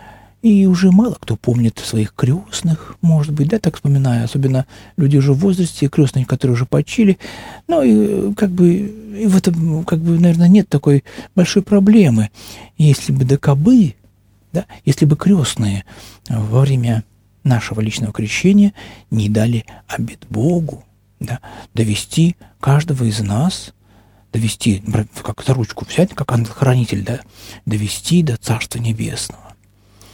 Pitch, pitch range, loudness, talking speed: 130 Hz, 110-170 Hz, -16 LUFS, 135 wpm